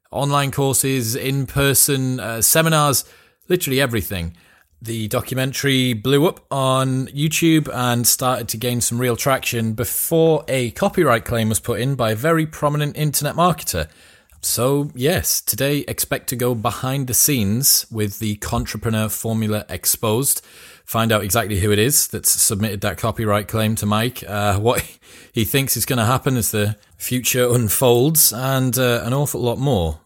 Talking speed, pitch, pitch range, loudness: 155 wpm, 125 Hz, 110-135 Hz, -18 LUFS